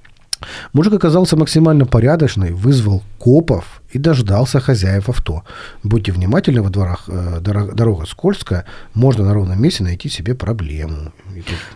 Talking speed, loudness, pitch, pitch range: 115 wpm, -15 LUFS, 105 Hz, 95-135 Hz